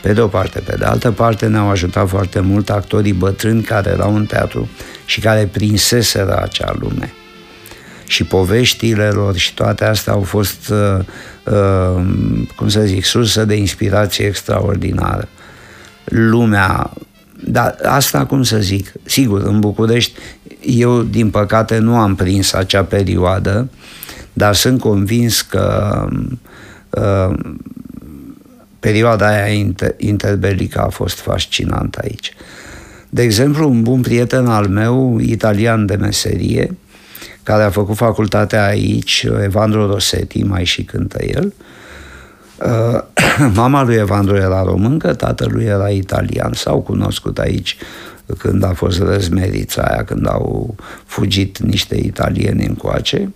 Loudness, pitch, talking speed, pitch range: -14 LUFS, 105 Hz, 125 wpm, 100-115 Hz